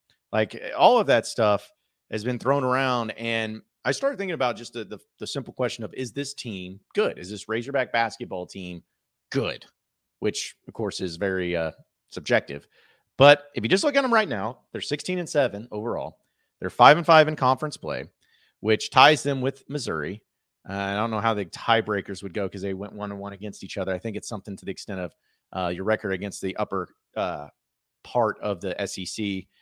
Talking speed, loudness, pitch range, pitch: 205 wpm, -25 LUFS, 100-130 Hz, 110 Hz